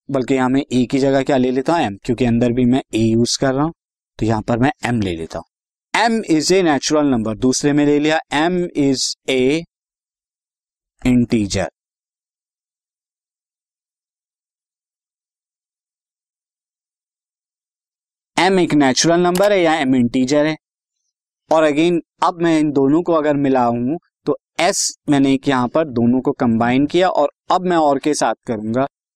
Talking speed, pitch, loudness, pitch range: 160 wpm, 135 Hz, -17 LUFS, 125-155 Hz